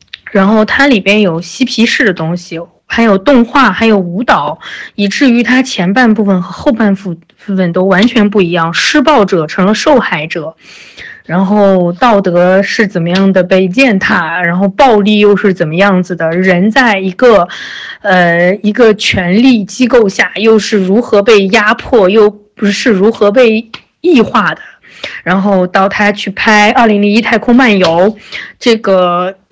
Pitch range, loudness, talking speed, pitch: 185-230 Hz, -8 LUFS, 235 characters per minute, 205 Hz